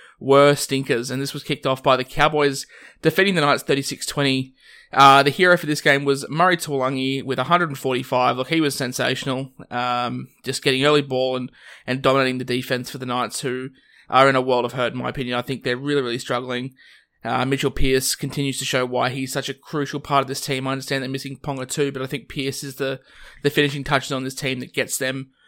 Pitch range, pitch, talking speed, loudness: 130-140 Hz, 135 Hz, 220 wpm, -21 LUFS